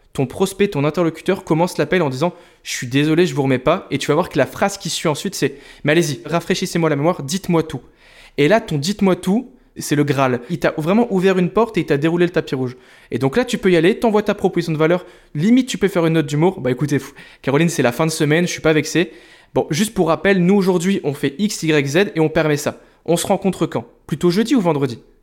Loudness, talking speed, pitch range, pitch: -18 LUFS, 255 wpm, 150-190 Hz, 170 Hz